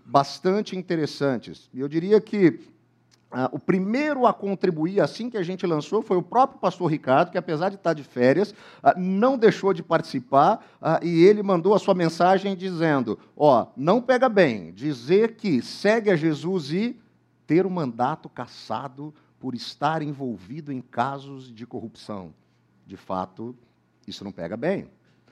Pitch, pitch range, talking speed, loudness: 165 Hz, 130-195 Hz, 165 wpm, -23 LUFS